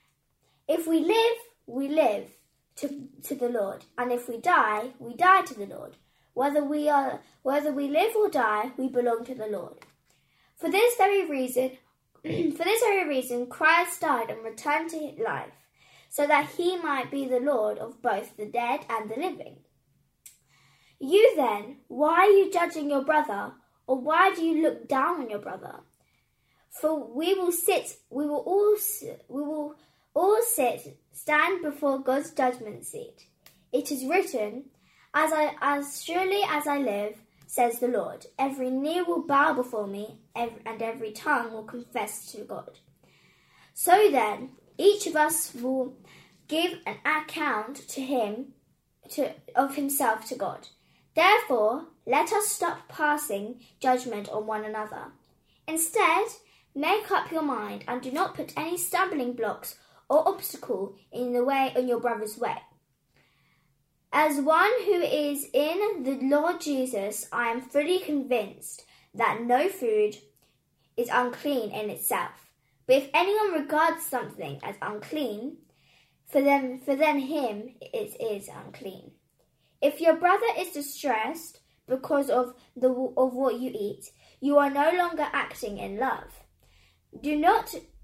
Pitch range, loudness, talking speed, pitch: 245-330 Hz, -27 LUFS, 150 wpm, 285 Hz